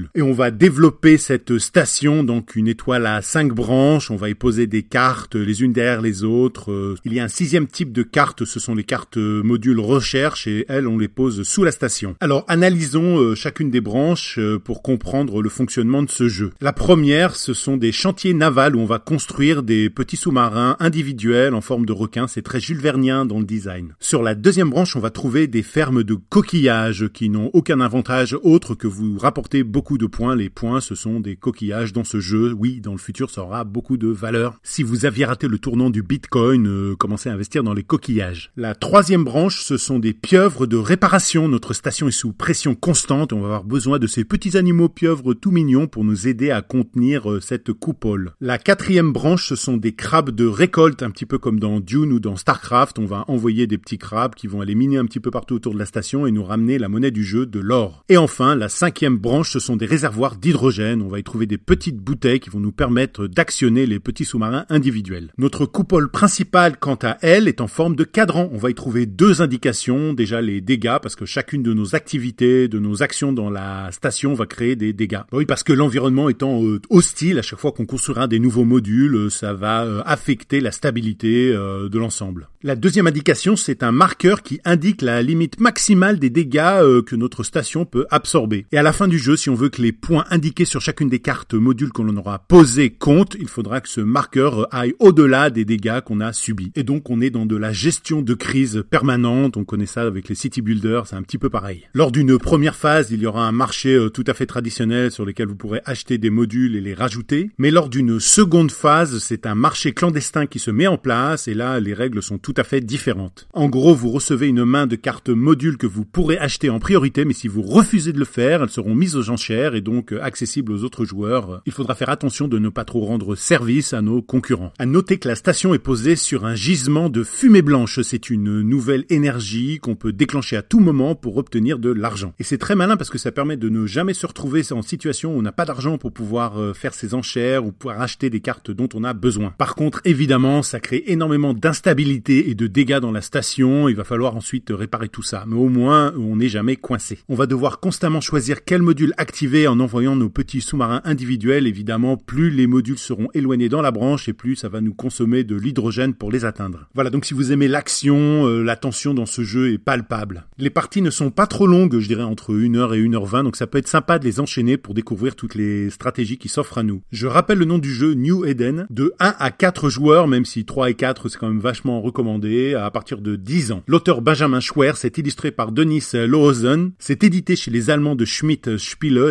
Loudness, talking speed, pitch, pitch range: -18 LUFS, 225 wpm, 125 Hz, 115-145 Hz